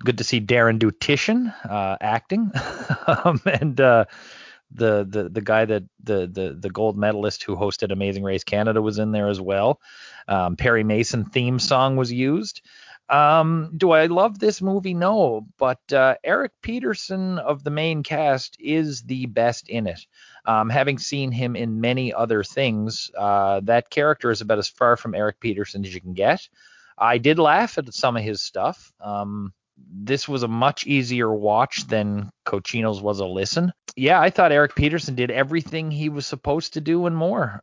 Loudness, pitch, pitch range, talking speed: -21 LUFS, 120 Hz, 105-150 Hz, 180 wpm